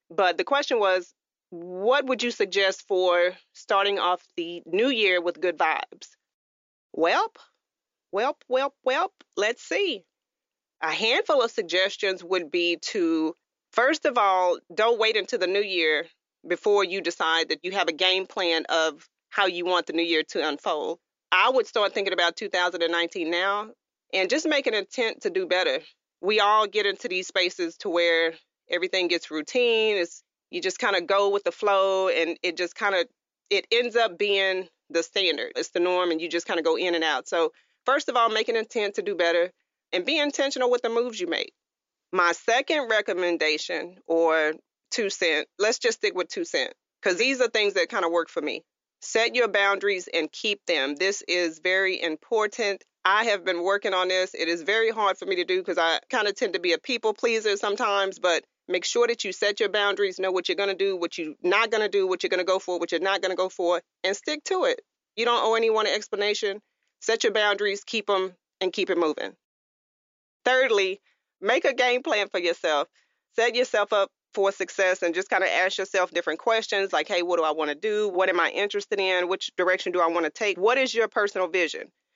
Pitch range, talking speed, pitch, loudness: 180-230 Hz, 205 wpm, 195 Hz, -25 LUFS